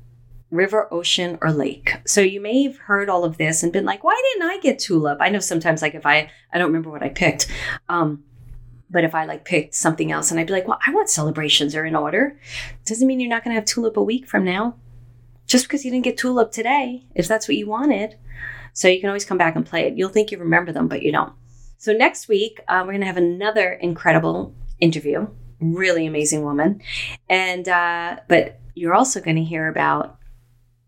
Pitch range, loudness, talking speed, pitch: 140-205 Hz, -20 LUFS, 225 wpm, 170 Hz